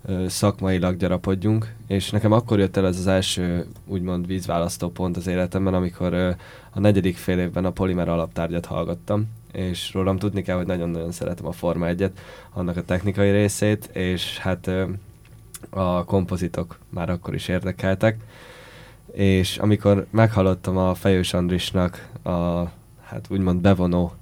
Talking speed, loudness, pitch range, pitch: 140 wpm, -23 LUFS, 90-100 Hz, 95 Hz